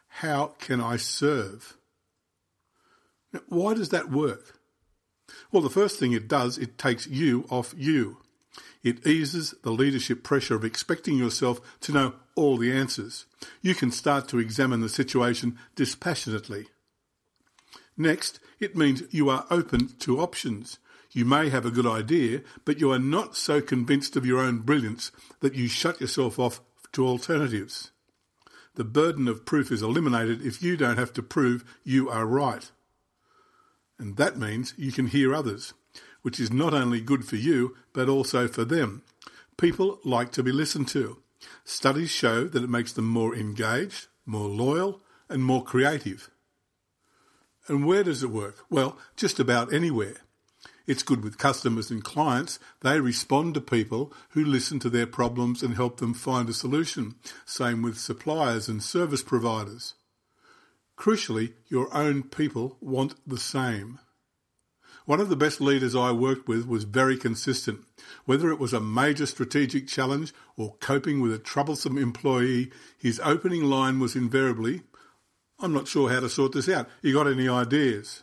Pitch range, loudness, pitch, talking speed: 120-145 Hz, -26 LUFS, 130 Hz, 160 wpm